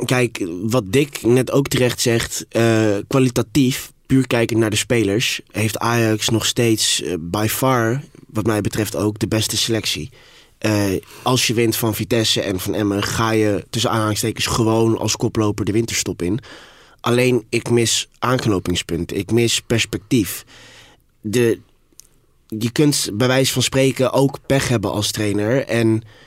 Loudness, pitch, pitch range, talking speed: -18 LUFS, 115 Hz, 105-125 Hz, 155 wpm